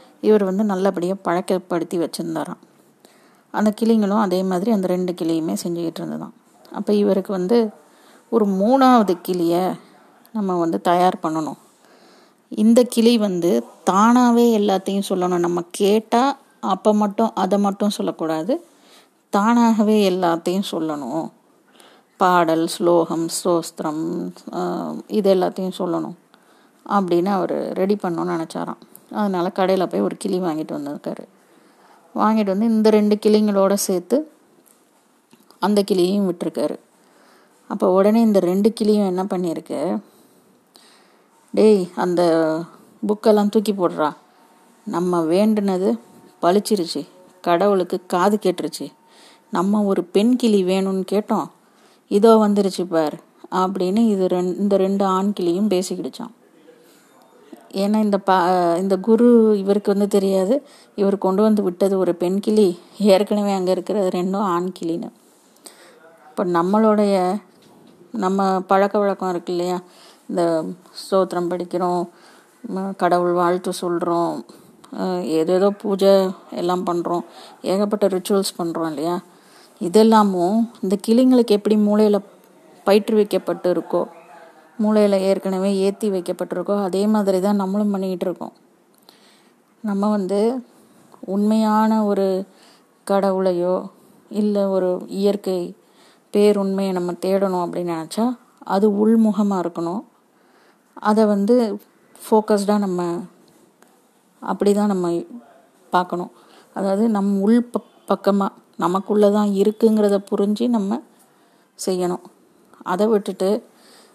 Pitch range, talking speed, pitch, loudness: 180-210 Hz, 105 wpm, 195 Hz, -19 LUFS